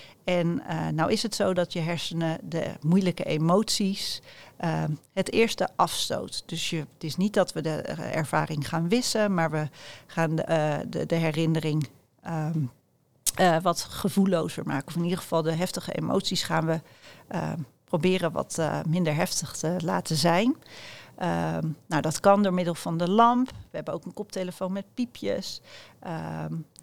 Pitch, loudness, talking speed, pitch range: 165 Hz, -27 LUFS, 170 wpm, 155-185 Hz